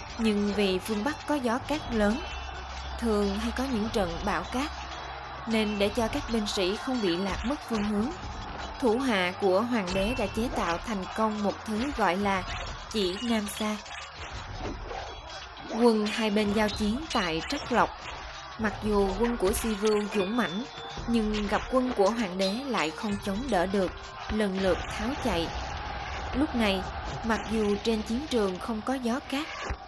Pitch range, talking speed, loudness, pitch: 200-230 Hz, 175 wpm, -29 LUFS, 215 Hz